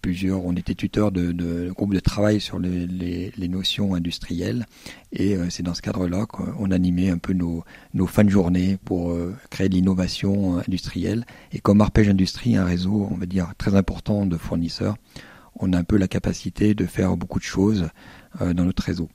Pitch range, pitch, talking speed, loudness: 90-100 Hz, 95 Hz, 205 wpm, -23 LUFS